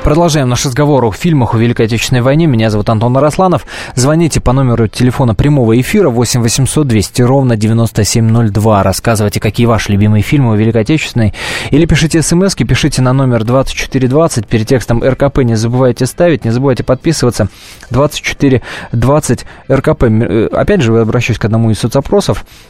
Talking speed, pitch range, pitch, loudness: 150 wpm, 115-140 Hz, 125 Hz, -10 LUFS